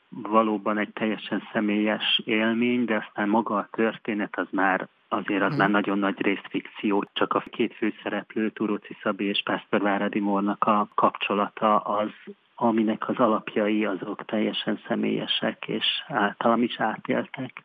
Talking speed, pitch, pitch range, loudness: 140 wpm, 105 Hz, 105-110 Hz, -25 LUFS